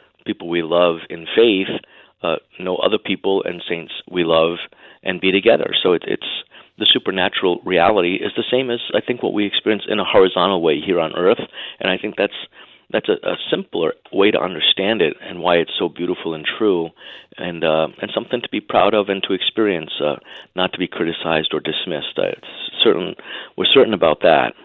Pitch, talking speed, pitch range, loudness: 90 Hz, 195 wpm, 85-95 Hz, -18 LUFS